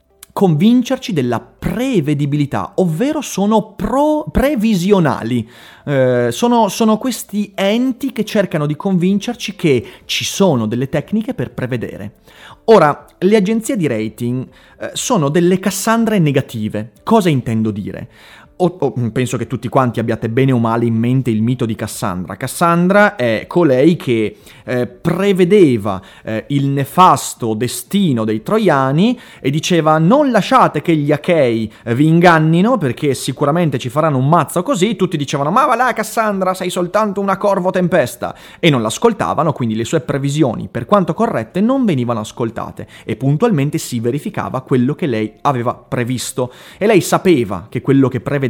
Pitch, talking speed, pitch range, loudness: 150 Hz, 145 wpm, 125-200 Hz, -15 LUFS